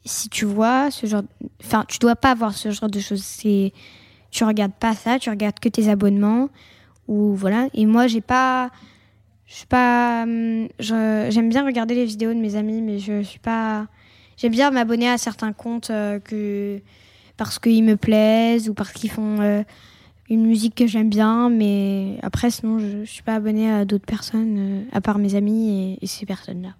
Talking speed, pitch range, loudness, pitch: 185 wpm, 205-230 Hz, -20 LUFS, 220 Hz